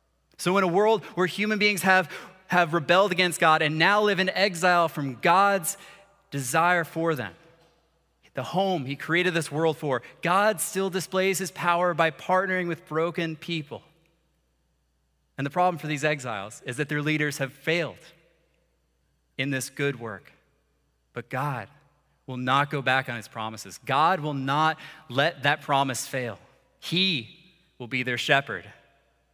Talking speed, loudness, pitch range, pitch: 155 wpm, -25 LUFS, 130-180 Hz, 155 Hz